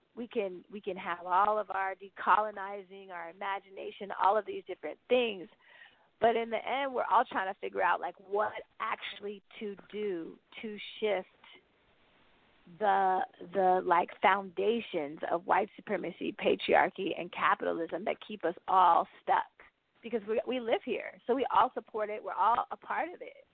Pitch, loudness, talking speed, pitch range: 200 Hz, -32 LUFS, 165 wpm, 185-220 Hz